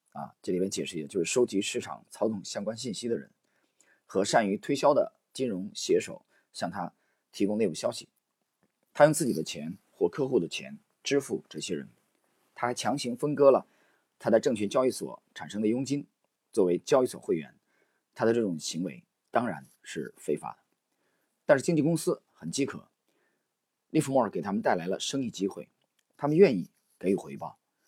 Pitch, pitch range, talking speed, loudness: 140 Hz, 120-160 Hz, 270 characters per minute, -29 LUFS